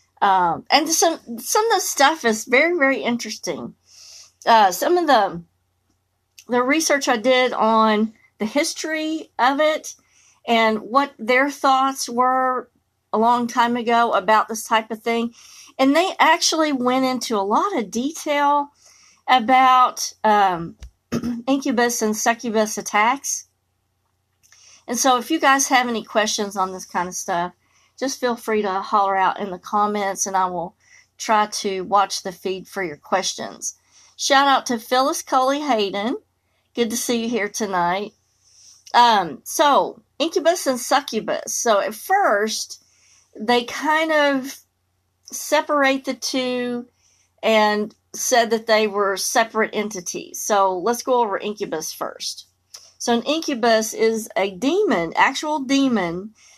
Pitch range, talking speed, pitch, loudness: 205-270 Hz, 140 wpm, 235 Hz, -20 LUFS